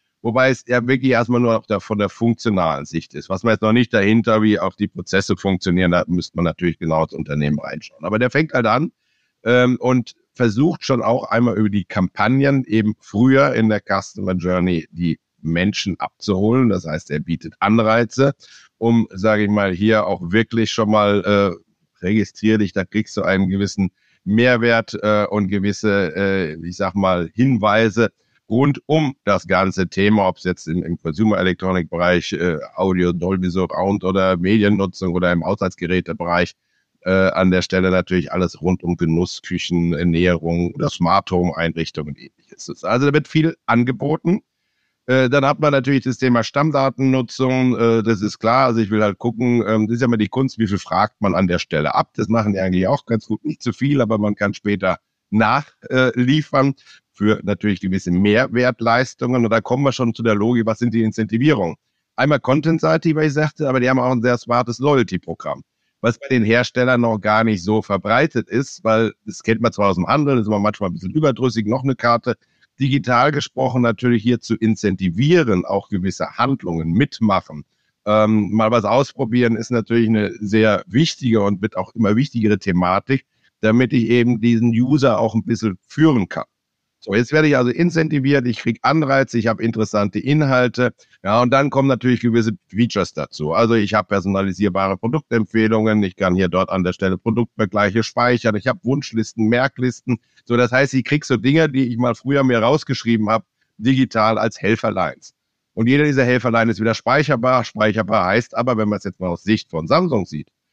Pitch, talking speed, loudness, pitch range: 110 Hz, 190 wpm, -18 LUFS, 100-125 Hz